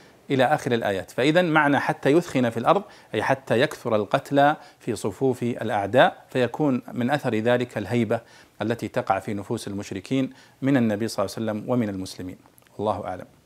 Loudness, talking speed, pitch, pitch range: -24 LUFS, 160 wpm, 120 Hz, 110-135 Hz